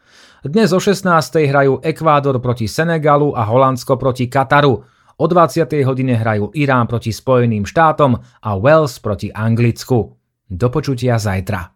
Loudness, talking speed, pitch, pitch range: -15 LUFS, 125 wpm, 130 Hz, 115-150 Hz